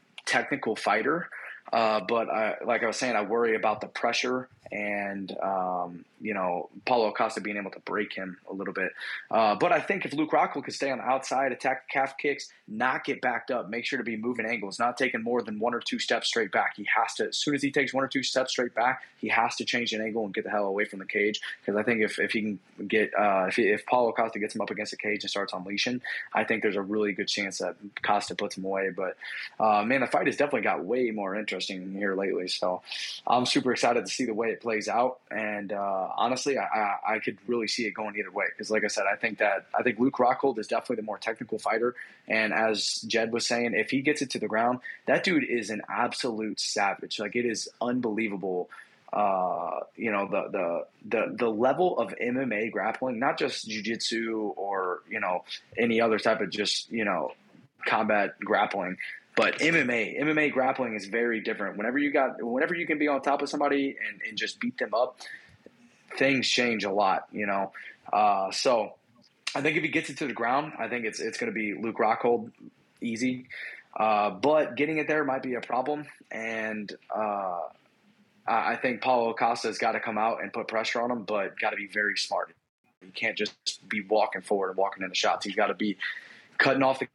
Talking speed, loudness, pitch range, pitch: 225 wpm, -28 LUFS, 105-125 Hz, 110 Hz